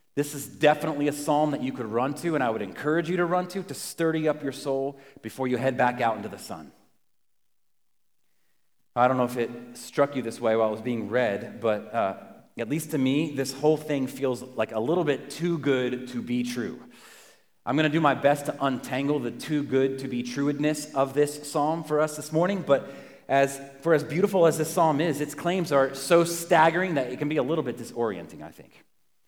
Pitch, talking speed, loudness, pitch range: 140 Hz, 225 wpm, -26 LUFS, 130-155 Hz